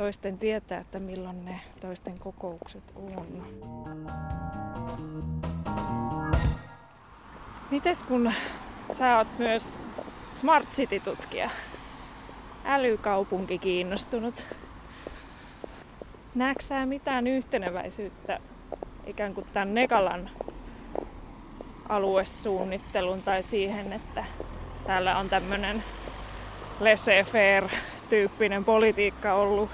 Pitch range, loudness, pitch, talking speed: 180-225 Hz, -28 LUFS, 195 Hz, 70 wpm